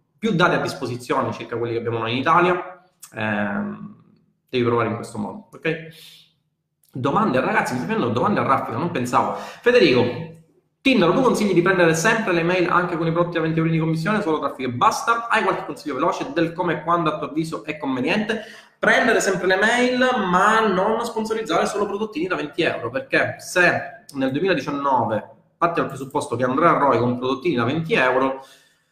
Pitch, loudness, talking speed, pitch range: 170 Hz, -20 LUFS, 185 wpm, 145-210 Hz